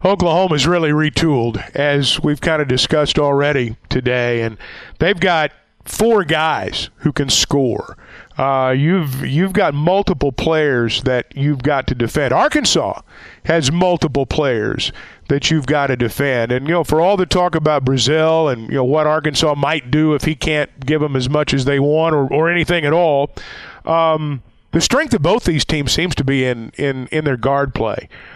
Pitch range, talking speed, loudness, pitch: 135-160 Hz, 180 wpm, -16 LUFS, 150 Hz